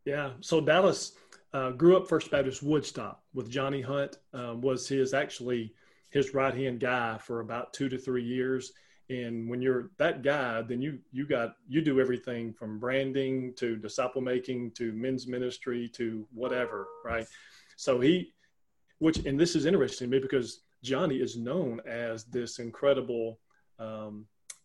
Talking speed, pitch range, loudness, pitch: 160 wpm, 120-135 Hz, -31 LUFS, 125 Hz